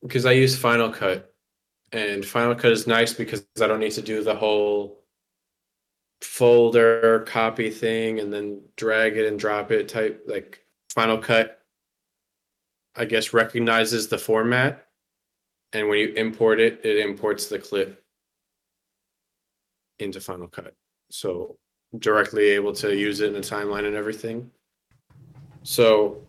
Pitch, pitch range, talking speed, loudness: 115 Hz, 105-125 Hz, 140 wpm, -22 LUFS